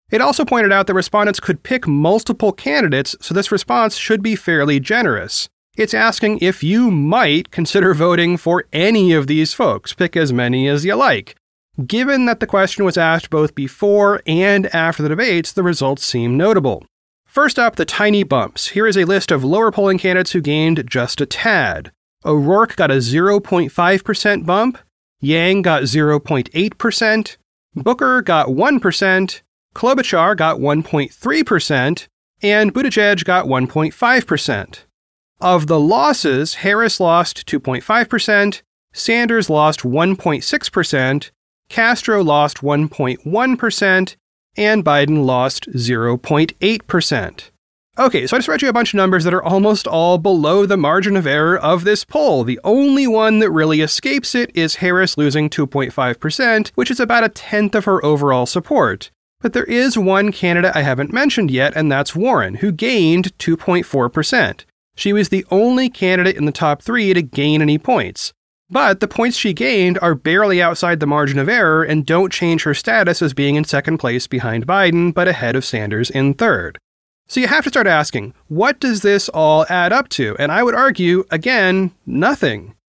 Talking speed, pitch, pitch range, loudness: 160 wpm, 180 Hz, 150-210 Hz, -15 LUFS